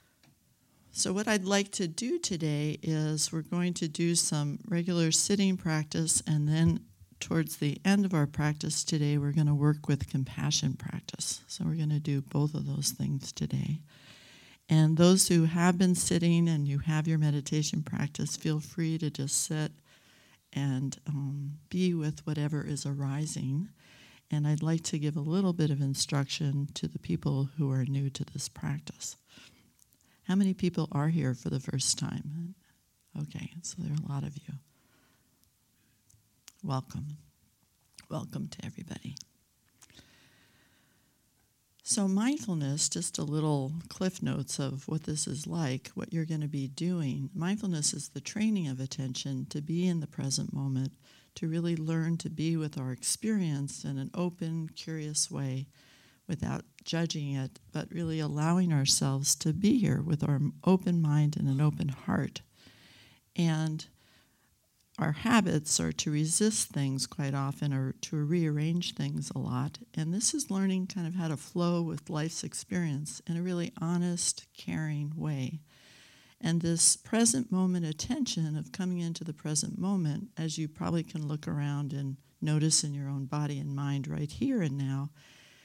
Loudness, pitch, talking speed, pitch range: -31 LUFS, 155 Hz, 160 wpm, 140-170 Hz